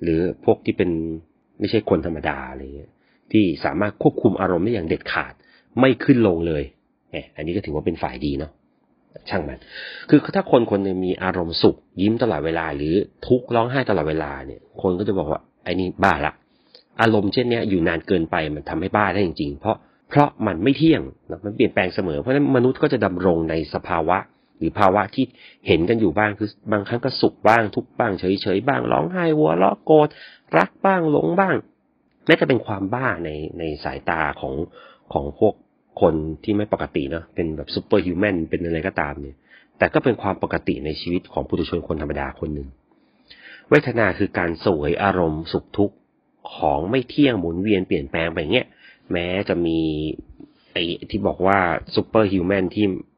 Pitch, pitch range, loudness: 95 Hz, 80-115 Hz, -21 LUFS